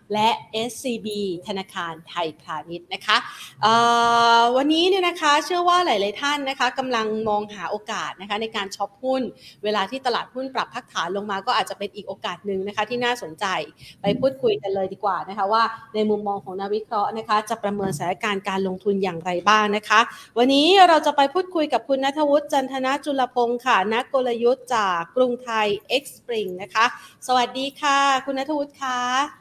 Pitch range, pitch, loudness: 200-265 Hz, 225 Hz, -22 LUFS